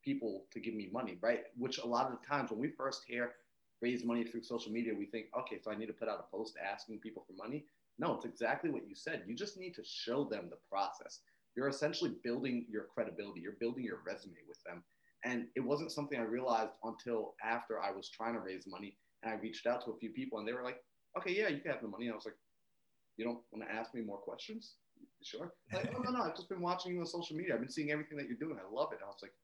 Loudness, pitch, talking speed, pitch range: -41 LUFS, 120 Hz, 265 wpm, 115-160 Hz